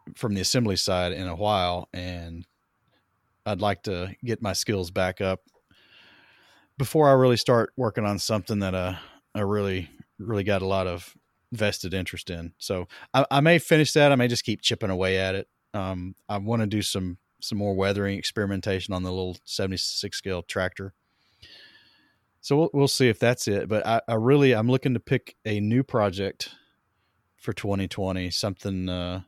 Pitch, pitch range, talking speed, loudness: 100 Hz, 95-115 Hz, 180 wpm, -25 LUFS